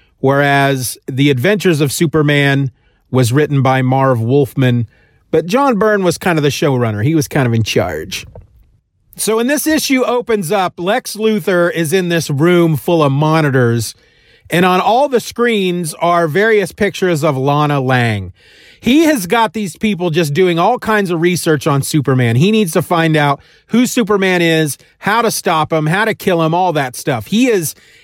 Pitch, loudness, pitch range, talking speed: 170 Hz, -13 LUFS, 140-205 Hz, 180 wpm